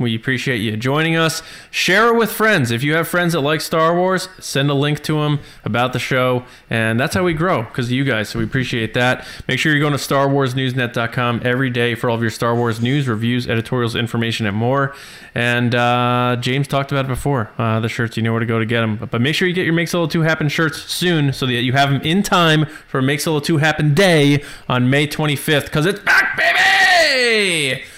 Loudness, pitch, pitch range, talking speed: -17 LUFS, 135 Hz, 120-160 Hz, 235 wpm